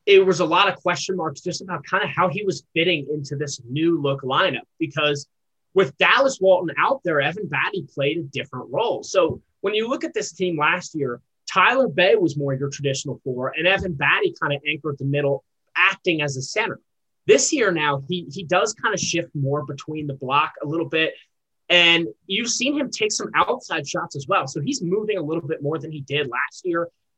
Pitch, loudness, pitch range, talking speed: 165 Hz, -21 LUFS, 145-190 Hz, 215 wpm